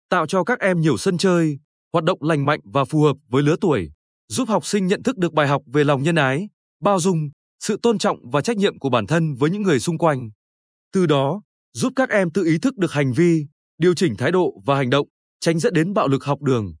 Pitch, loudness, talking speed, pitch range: 160 Hz, -20 LUFS, 250 wpm, 140-190 Hz